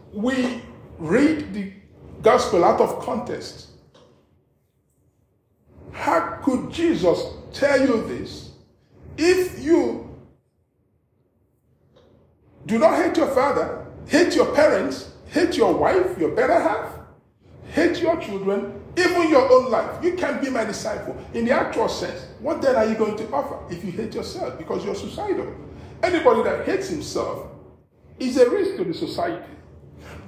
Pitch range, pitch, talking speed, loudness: 220-340 Hz, 280 Hz, 135 wpm, -21 LUFS